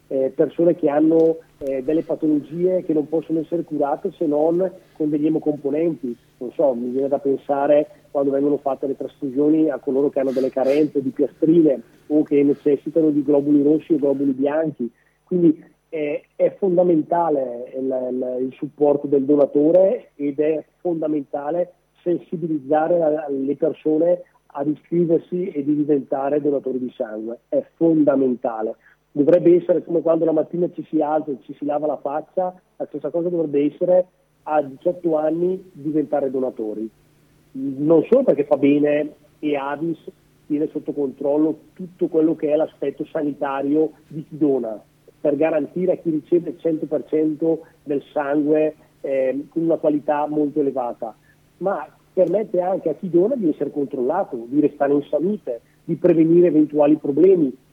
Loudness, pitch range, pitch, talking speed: -20 LUFS, 145-165 Hz, 150 Hz, 155 wpm